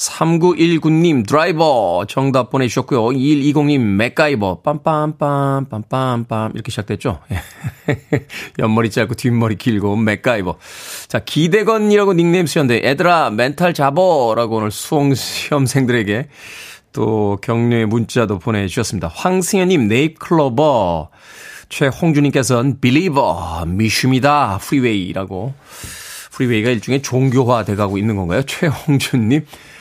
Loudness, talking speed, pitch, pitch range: -16 LUFS, 290 characters per minute, 130 Hz, 110-150 Hz